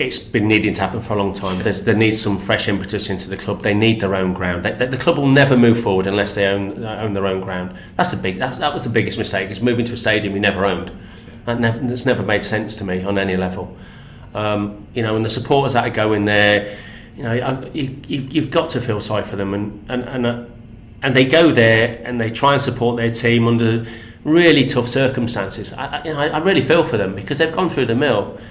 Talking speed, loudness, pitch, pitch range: 260 wpm, -17 LUFS, 110 Hz, 100-120 Hz